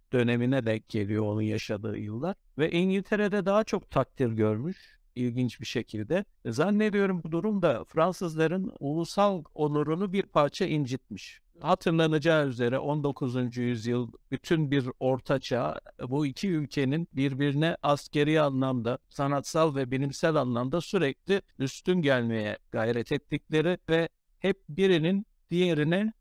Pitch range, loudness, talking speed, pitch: 125-175 Hz, -28 LUFS, 115 wpm, 145 Hz